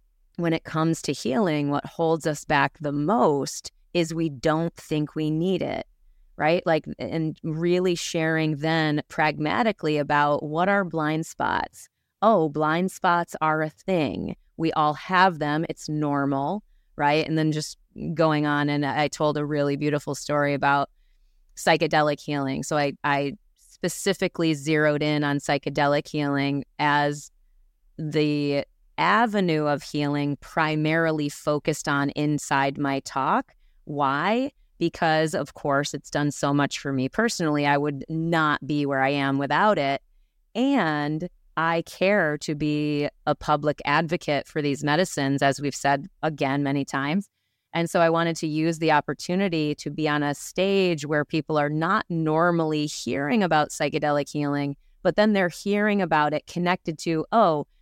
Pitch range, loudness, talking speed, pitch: 145-165 Hz, -24 LUFS, 150 wpm, 155 Hz